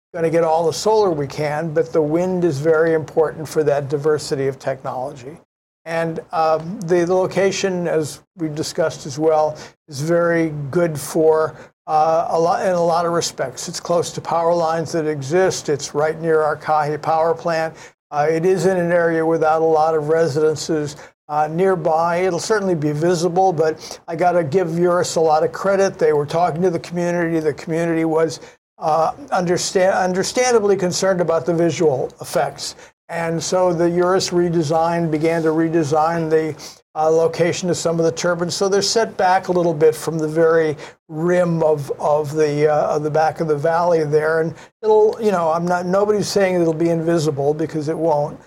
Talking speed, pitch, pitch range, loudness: 185 wpm, 165 Hz, 155-175 Hz, -18 LUFS